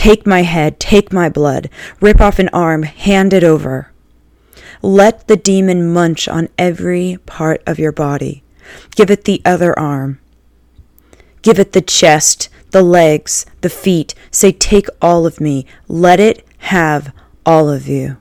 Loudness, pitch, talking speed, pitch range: -12 LUFS, 170 Hz, 155 wpm, 150-190 Hz